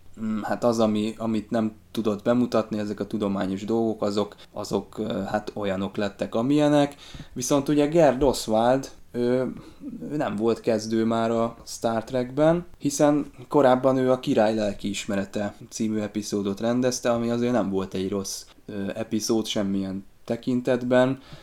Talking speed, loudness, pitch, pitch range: 135 wpm, -25 LUFS, 115 Hz, 105-125 Hz